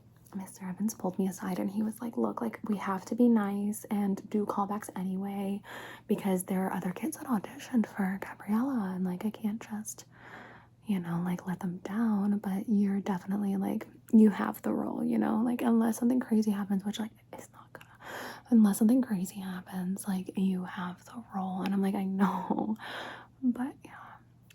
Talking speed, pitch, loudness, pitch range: 185 wpm, 200 Hz, -31 LUFS, 190-220 Hz